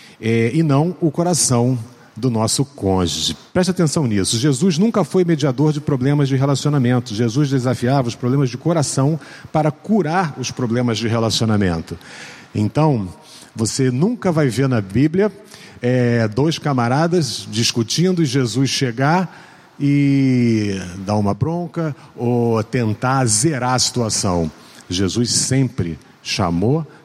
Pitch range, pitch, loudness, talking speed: 115-155 Hz, 130 Hz, -18 LUFS, 125 wpm